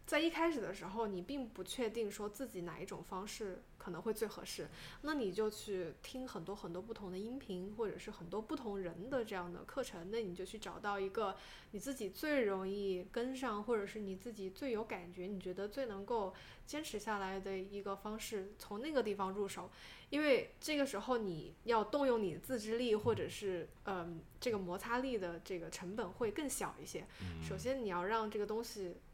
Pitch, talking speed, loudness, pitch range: 205 Hz, 300 characters per minute, -41 LUFS, 190-240 Hz